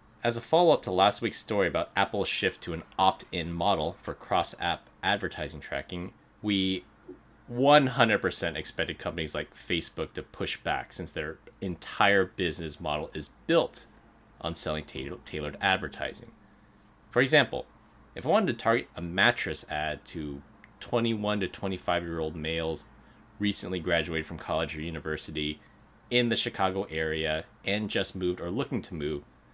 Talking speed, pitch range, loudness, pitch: 155 wpm, 80-105 Hz, -29 LUFS, 90 Hz